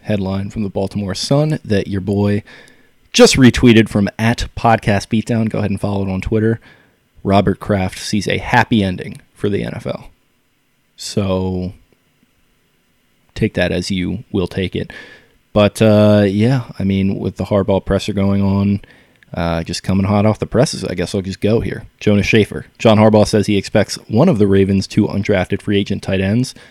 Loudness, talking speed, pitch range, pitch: -16 LUFS, 180 wpm, 95-110 Hz, 100 Hz